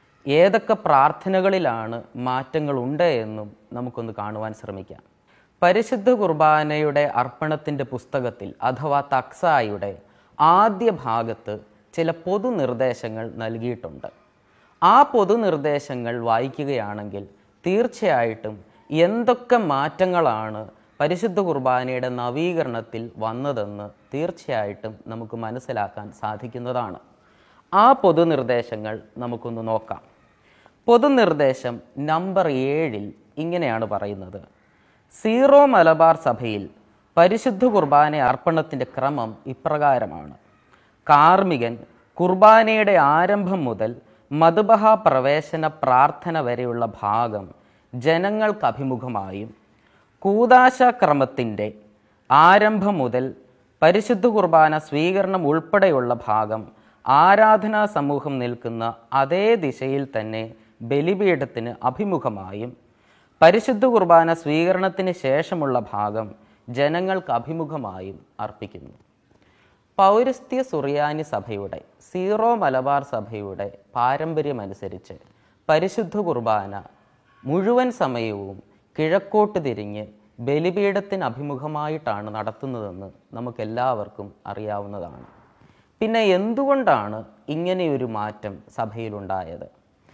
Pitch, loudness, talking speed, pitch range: 130 Hz, -20 LUFS, 70 wpm, 110-170 Hz